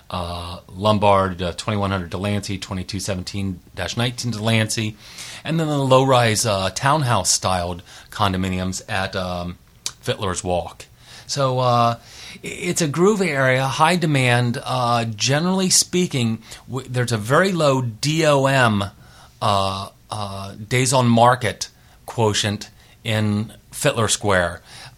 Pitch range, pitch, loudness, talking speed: 100-130 Hz, 115 Hz, -20 LUFS, 115 wpm